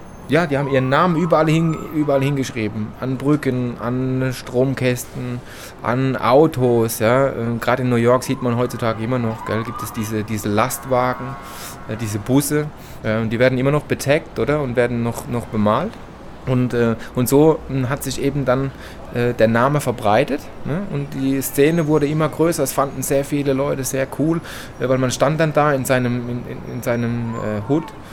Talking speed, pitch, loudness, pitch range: 170 wpm, 130 Hz, -19 LUFS, 115-140 Hz